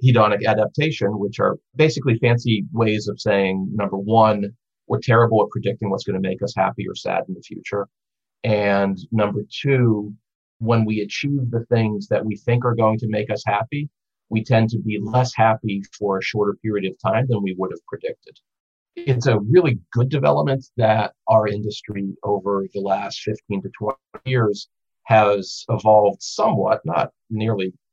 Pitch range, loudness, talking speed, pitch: 100-120 Hz, -20 LUFS, 170 wpm, 110 Hz